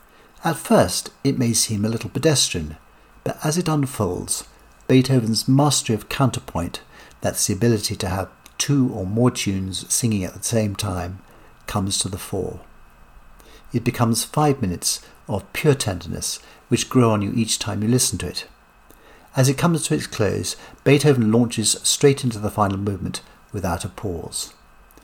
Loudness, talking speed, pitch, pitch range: -21 LUFS, 160 wpm, 115 Hz, 100-130 Hz